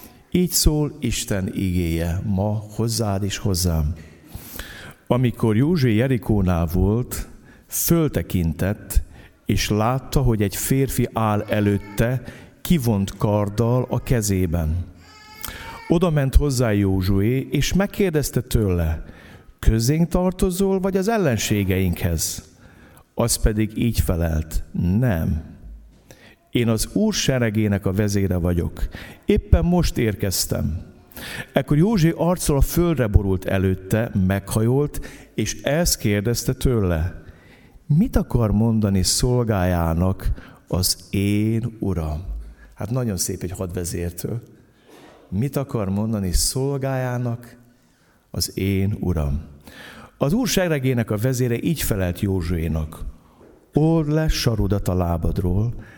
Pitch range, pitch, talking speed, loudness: 90-125 Hz, 105 Hz, 100 wpm, -21 LUFS